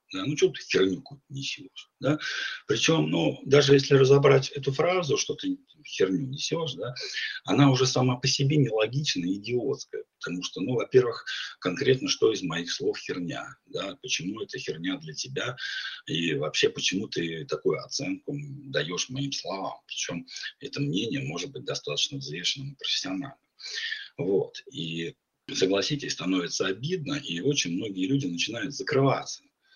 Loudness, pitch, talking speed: -27 LUFS, 140 Hz, 145 wpm